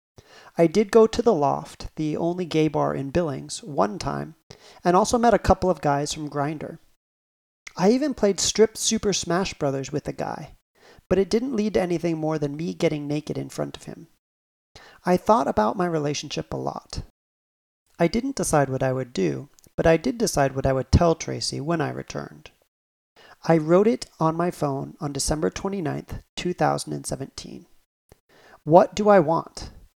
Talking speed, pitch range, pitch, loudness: 175 wpm, 135-185 Hz, 160 Hz, -23 LUFS